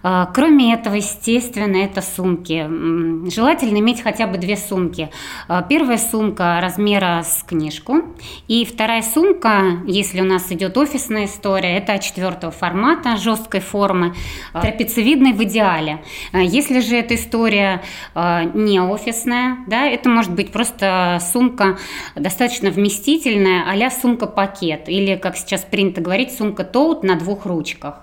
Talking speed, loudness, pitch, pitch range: 125 wpm, -17 LUFS, 200 Hz, 185-235 Hz